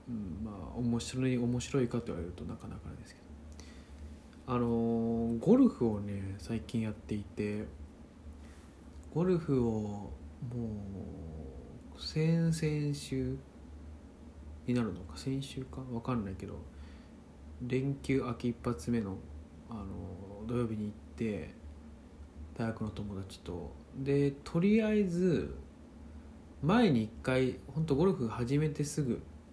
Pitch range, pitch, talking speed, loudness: 75-130 Hz, 105 Hz, 215 characters per minute, -34 LUFS